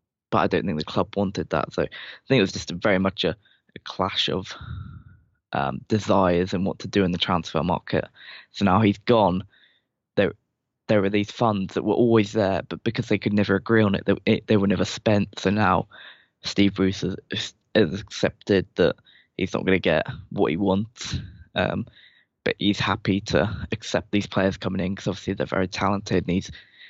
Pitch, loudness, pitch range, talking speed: 100 Hz, -24 LUFS, 95-105 Hz, 200 wpm